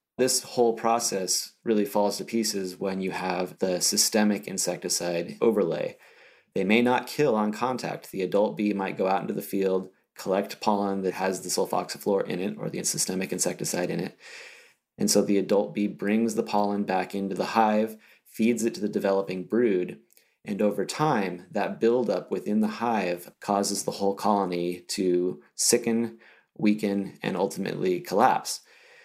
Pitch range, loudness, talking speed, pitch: 95-115 Hz, -26 LUFS, 165 wpm, 105 Hz